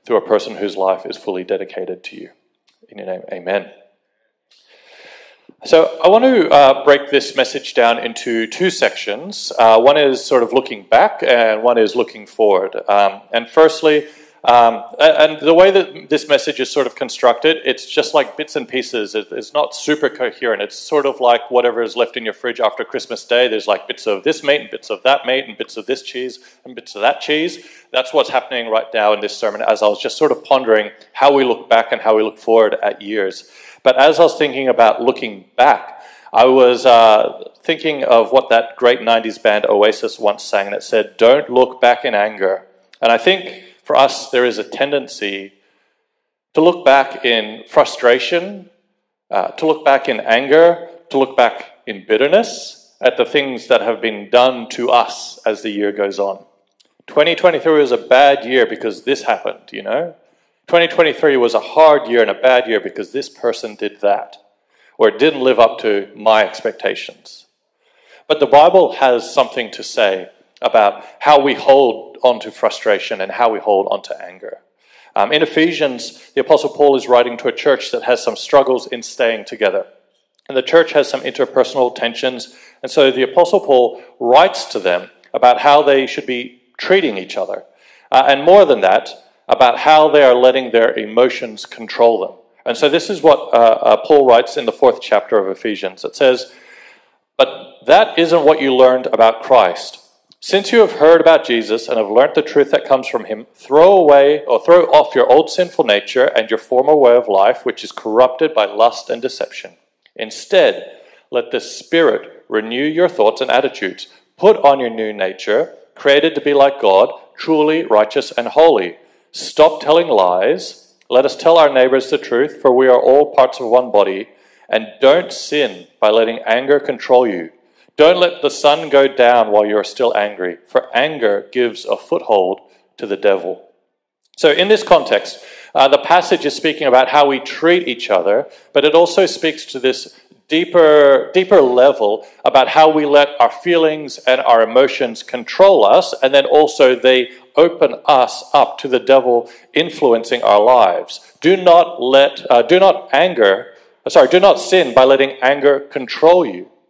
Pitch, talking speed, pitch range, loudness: 140 Hz, 190 wpm, 120-175 Hz, -13 LUFS